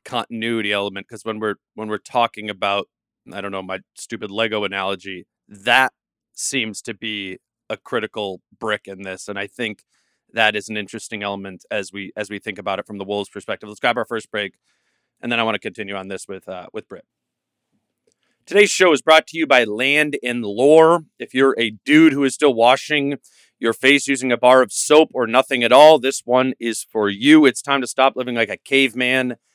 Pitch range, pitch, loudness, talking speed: 100-135 Hz, 115 Hz, -18 LUFS, 210 wpm